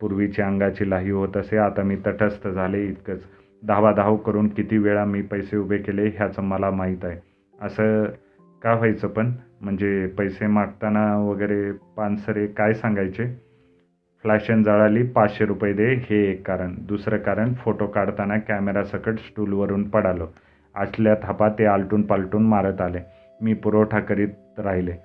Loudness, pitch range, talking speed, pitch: -22 LUFS, 100-105 Hz, 140 wpm, 105 Hz